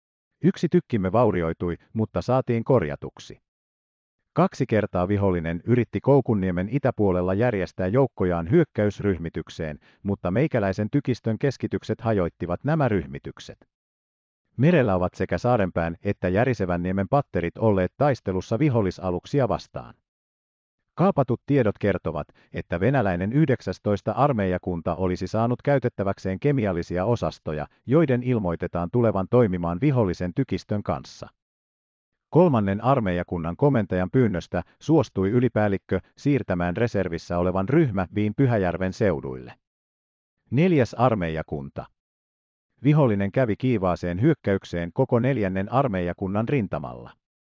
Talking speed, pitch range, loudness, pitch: 95 wpm, 85-125 Hz, -24 LUFS, 100 Hz